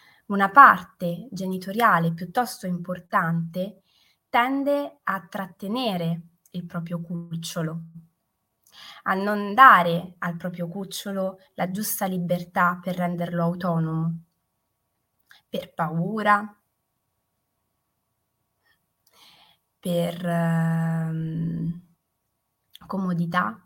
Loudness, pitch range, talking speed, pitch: -23 LUFS, 170-195 Hz, 70 wpm, 180 Hz